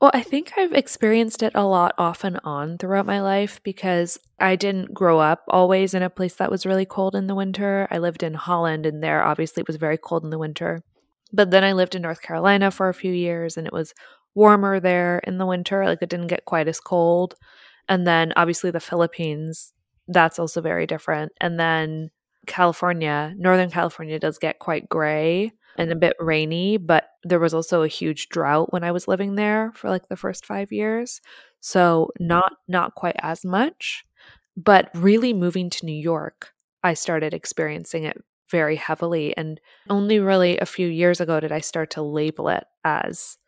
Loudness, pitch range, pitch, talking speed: -21 LUFS, 160-195 Hz, 175 Hz, 195 wpm